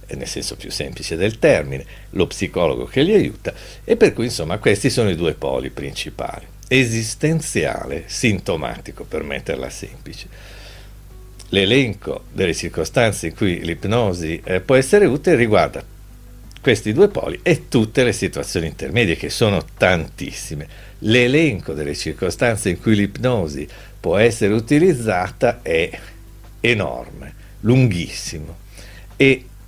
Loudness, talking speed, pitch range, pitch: -19 LUFS, 125 wpm, 90-120 Hz, 100 Hz